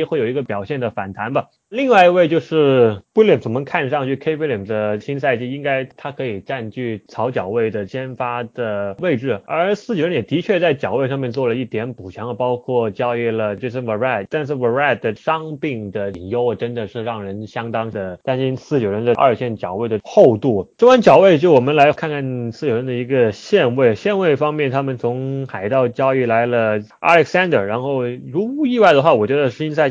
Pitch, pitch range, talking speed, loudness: 130 Hz, 115-150 Hz, 335 characters per minute, -18 LUFS